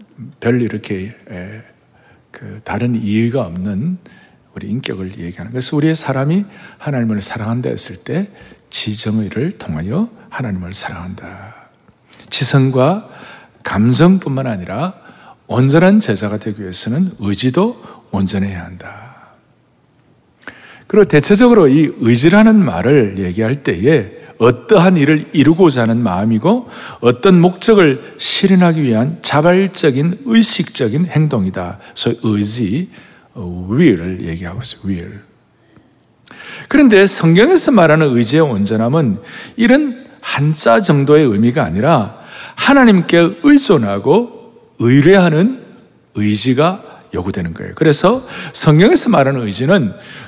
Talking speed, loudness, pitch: 275 characters per minute, -13 LUFS, 145 Hz